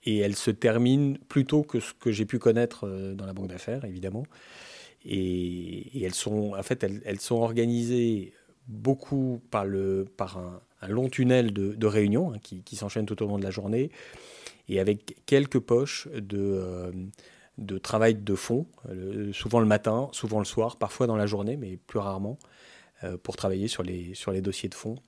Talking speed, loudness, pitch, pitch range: 185 wpm, -28 LUFS, 105 Hz, 95-120 Hz